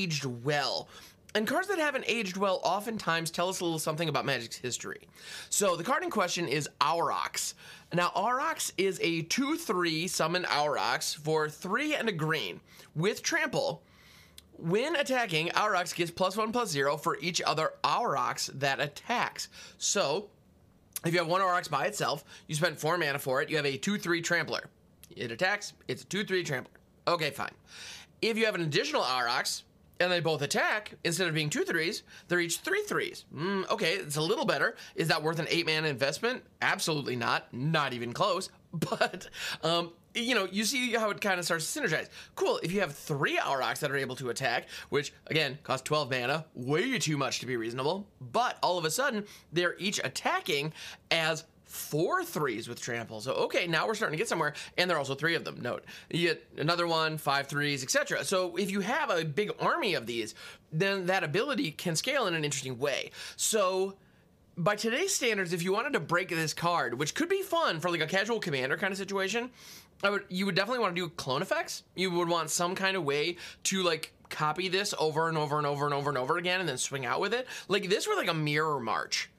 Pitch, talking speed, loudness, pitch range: 170 Hz, 205 wpm, -30 LUFS, 150-200 Hz